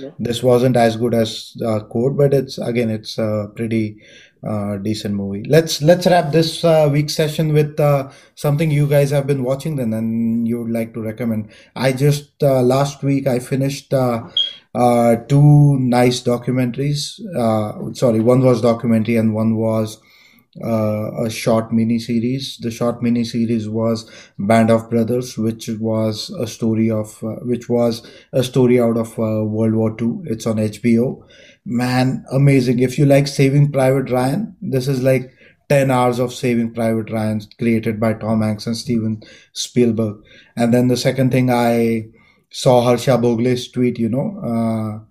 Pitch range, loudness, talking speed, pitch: 115-135 Hz, -17 LUFS, 170 wpm, 120 Hz